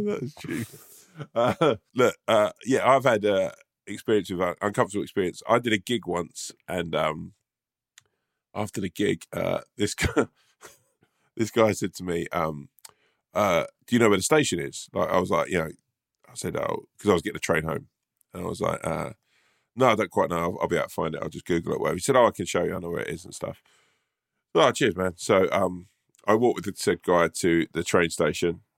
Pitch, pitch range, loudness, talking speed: 90 Hz, 85-115 Hz, -25 LUFS, 225 wpm